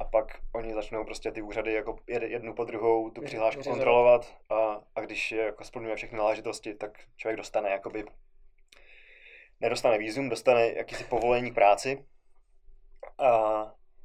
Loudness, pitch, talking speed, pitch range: -28 LUFS, 115 Hz, 145 wpm, 110-125 Hz